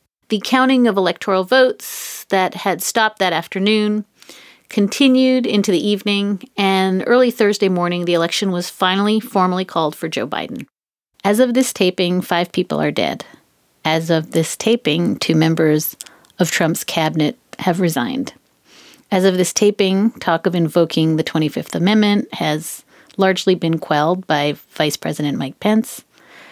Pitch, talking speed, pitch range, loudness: 185 Hz, 145 wpm, 165-210 Hz, -17 LUFS